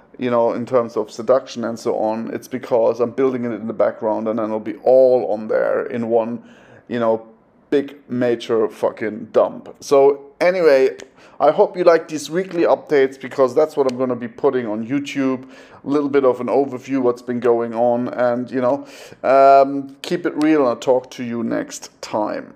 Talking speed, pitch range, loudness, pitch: 200 wpm, 120-140 Hz, -18 LUFS, 130 Hz